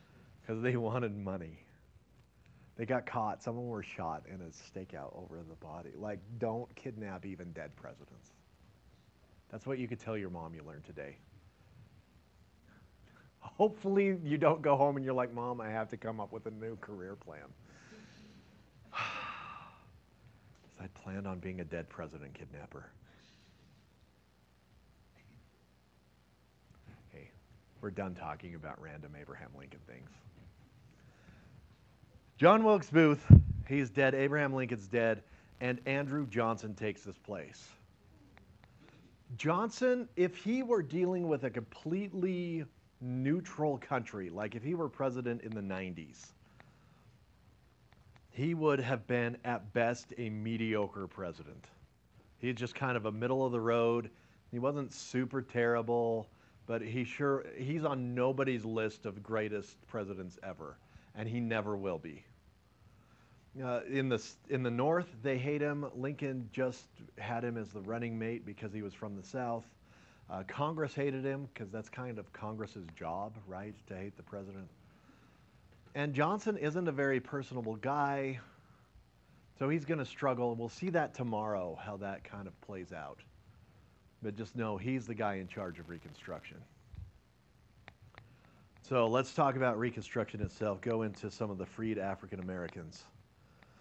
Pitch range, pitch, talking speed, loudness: 100-130 Hz, 115 Hz, 145 wpm, -35 LUFS